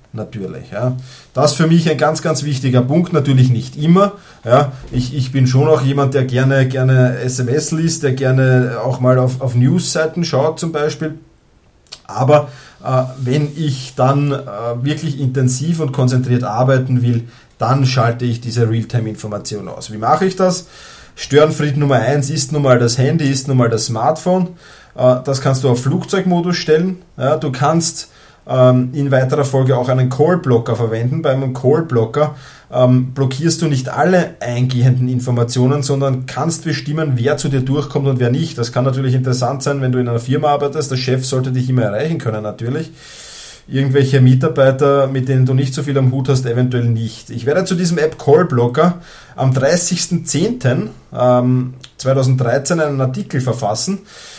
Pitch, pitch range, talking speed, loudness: 135 Hz, 125-150 Hz, 165 wpm, -15 LUFS